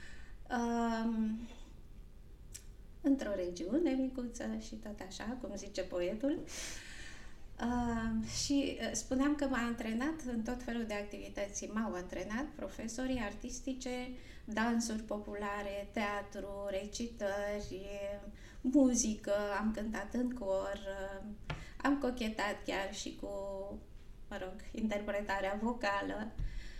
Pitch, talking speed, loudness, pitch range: 220 Hz, 100 wpm, -38 LUFS, 200-250 Hz